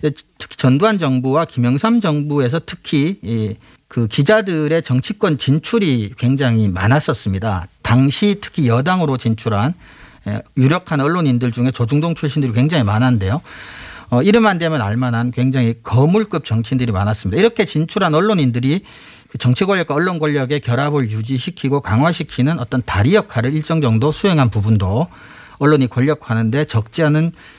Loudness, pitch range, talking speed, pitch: -16 LUFS, 120-160 Hz, 350 characters per minute, 135 Hz